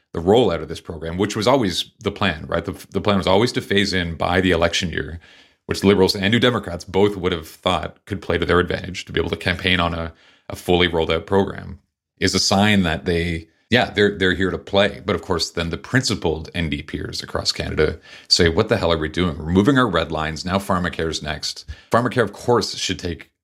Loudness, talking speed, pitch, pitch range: -20 LUFS, 230 wpm, 90 Hz, 85-100 Hz